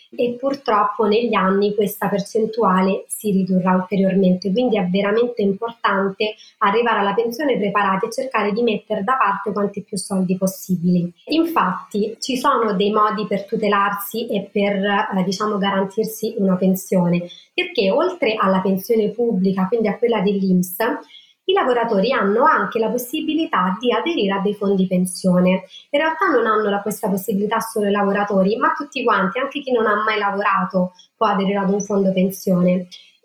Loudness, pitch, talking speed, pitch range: -19 LUFS, 205 Hz, 155 wpm, 195-225 Hz